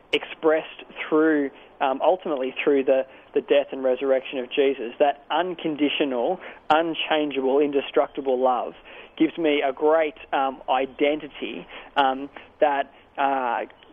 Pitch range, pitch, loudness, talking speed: 135-155 Hz, 145 Hz, -24 LUFS, 110 wpm